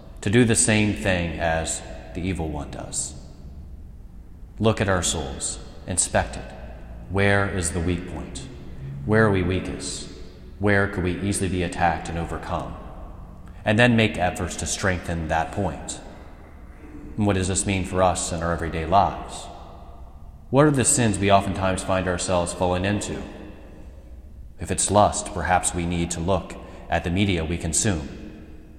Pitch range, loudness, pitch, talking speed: 80-95 Hz, -23 LUFS, 90 Hz, 155 wpm